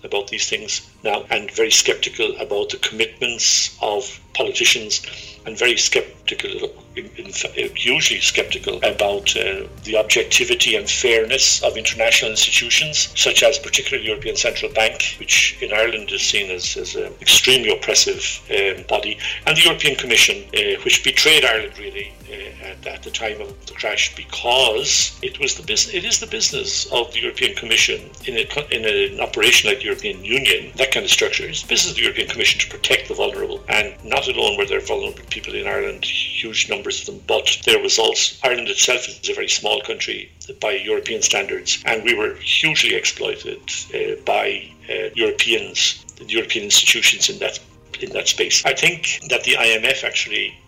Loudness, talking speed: -17 LUFS, 175 wpm